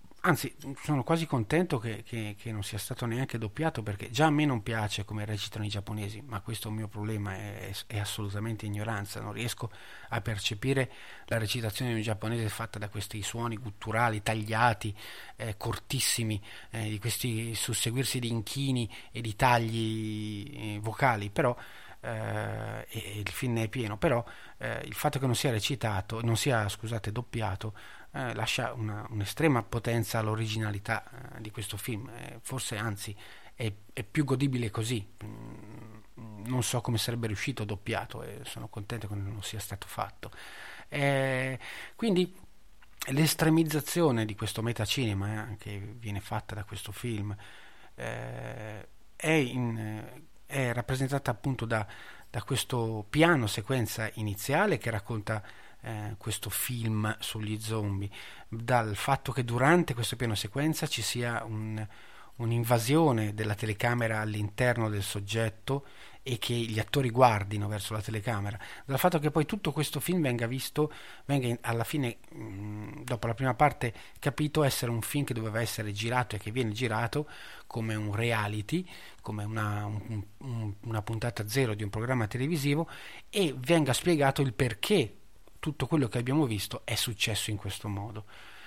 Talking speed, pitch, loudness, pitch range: 155 wpm, 115 Hz, -31 LUFS, 105-130 Hz